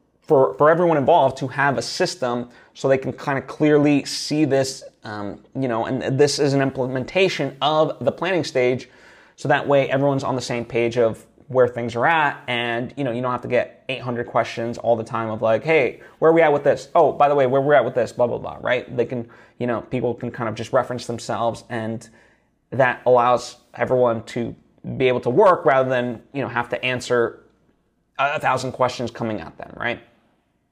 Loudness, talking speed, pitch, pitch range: -20 LUFS, 215 wpm, 125 Hz, 120-140 Hz